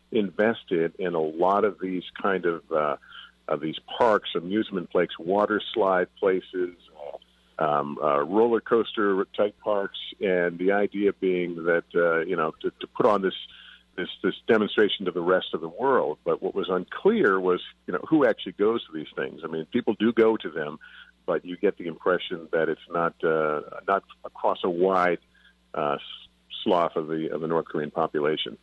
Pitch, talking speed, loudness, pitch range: 95 Hz, 180 wpm, -26 LUFS, 80-120 Hz